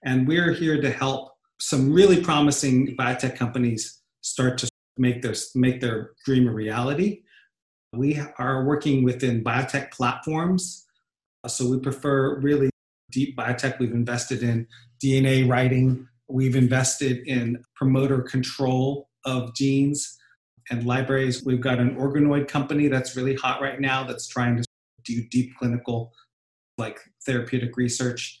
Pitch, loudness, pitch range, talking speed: 130 Hz, -24 LUFS, 125-135 Hz, 135 wpm